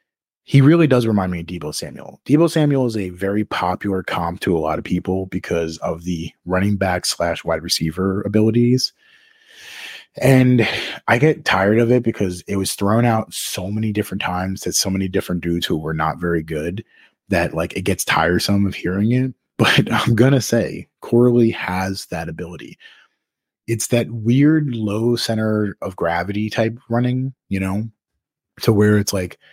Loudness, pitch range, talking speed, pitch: -19 LUFS, 90-120 Hz, 175 wpm, 105 Hz